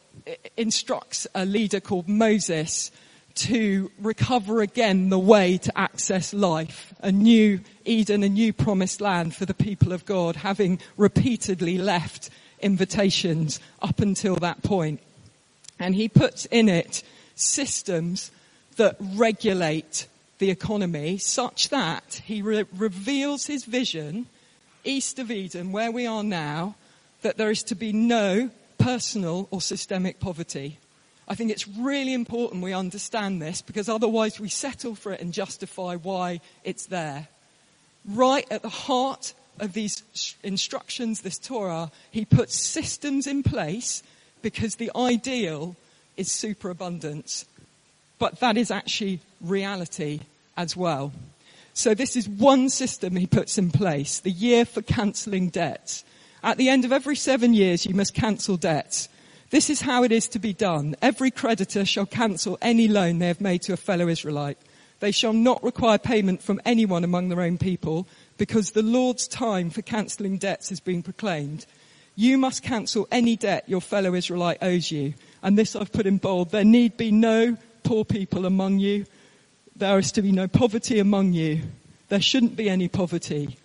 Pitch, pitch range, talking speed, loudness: 200 Hz, 175-225 Hz, 155 wpm, -24 LUFS